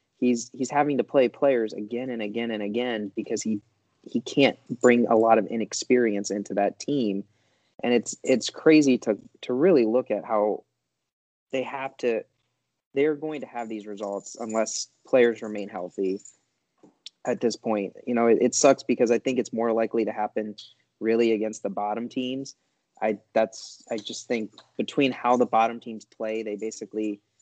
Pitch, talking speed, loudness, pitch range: 115 Hz, 175 wpm, -25 LUFS, 105-125 Hz